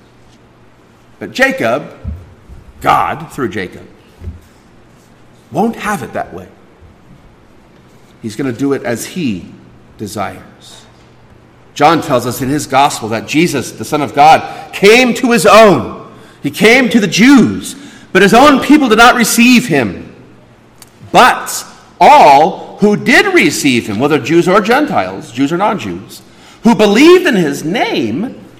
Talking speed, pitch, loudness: 140 wpm, 205 Hz, -10 LUFS